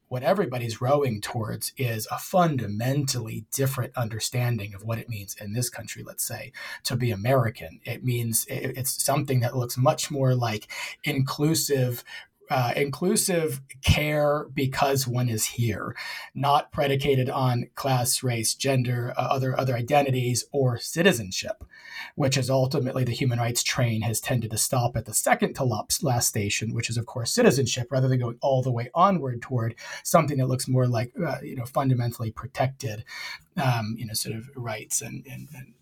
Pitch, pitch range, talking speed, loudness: 125 Hz, 115-135 Hz, 165 wpm, -26 LUFS